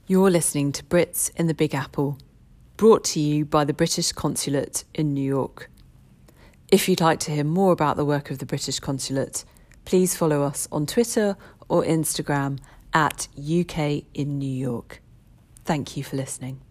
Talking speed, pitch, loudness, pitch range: 170 wpm, 145 Hz, -23 LUFS, 135-165 Hz